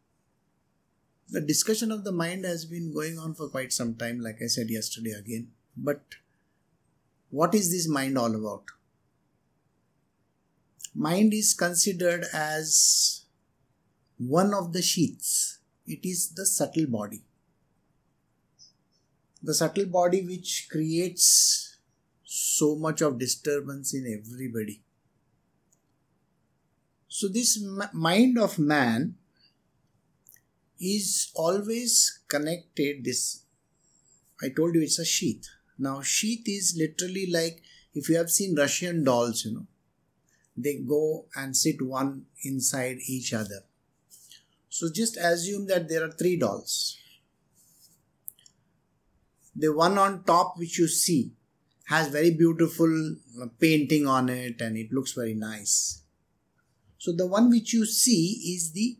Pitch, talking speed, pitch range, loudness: 160 Hz, 120 wpm, 130-180 Hz, -26 LUFS